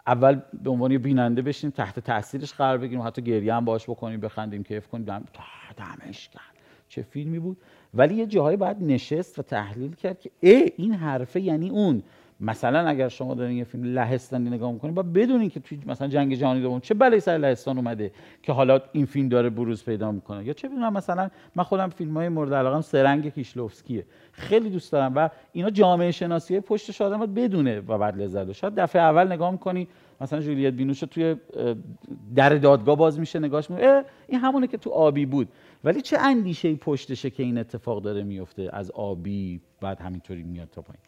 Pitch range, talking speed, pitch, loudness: 120-175 Hz, 190 wpm, 140 Hz, -24 LUFS